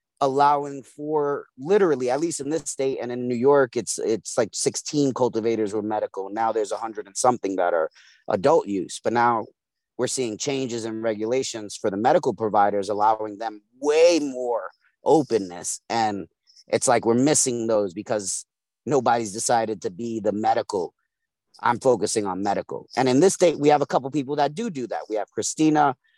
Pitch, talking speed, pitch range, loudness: 125 Hz, 175 wpm, 110-145 Hz, -23 LUFS